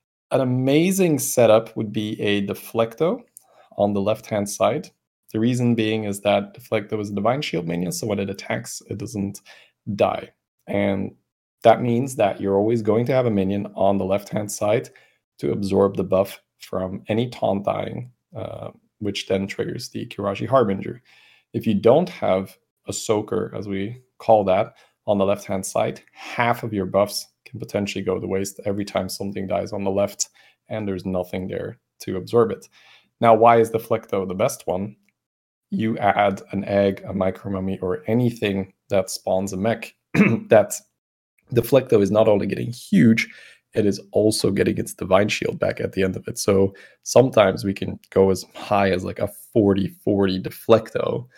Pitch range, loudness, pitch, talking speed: 95-115 Hz, -22 LUFS, 100 Hz, 180 wpm